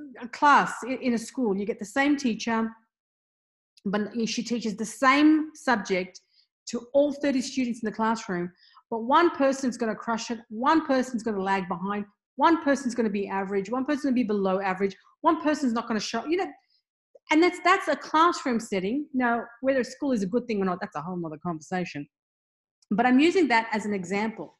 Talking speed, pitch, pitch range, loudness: 205 wpm, 235 Hz, 205-275 Hz, -26 LUFS